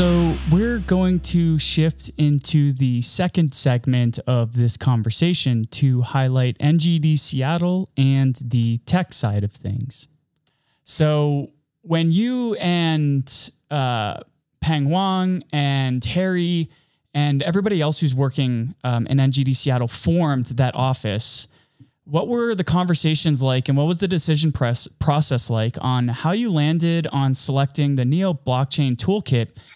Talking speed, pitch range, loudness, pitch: 130 wpm, 130-165 Hz, -19 LUFS, 145 Hz